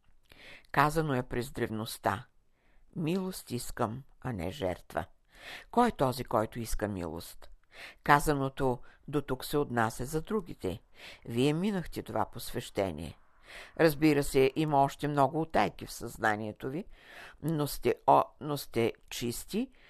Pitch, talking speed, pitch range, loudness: 130 Hz, 125 wpm, 115-150 Hz, -32 LUFS